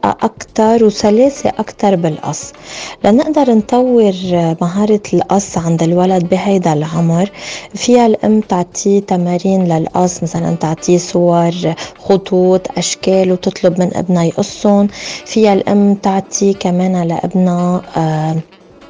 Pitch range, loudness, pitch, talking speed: 175-200 Hz, -13 LUFS, 185 Hz, 100 wpm